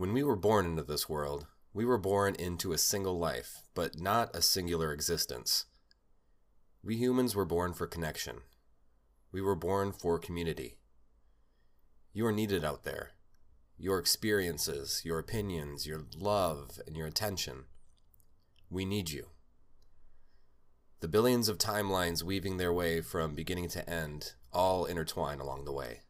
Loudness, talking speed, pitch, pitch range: -33 LUFS, 145 wpm, 85 Hz, 75-100 Hz